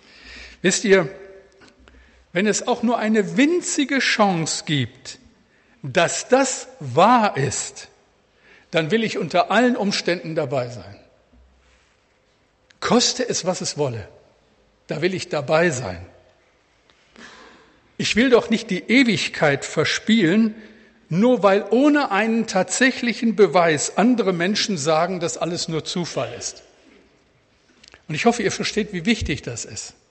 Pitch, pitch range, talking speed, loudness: 195 Hz, 160-225 Hz, 125 wpm, -20 LUFS